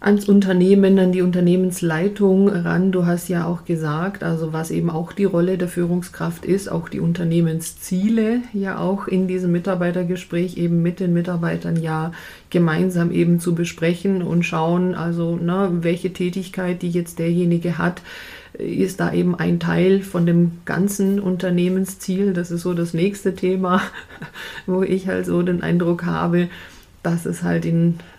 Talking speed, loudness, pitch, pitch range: 155 wpm, -20 LUFS, 175 Hz, 170-185 Hz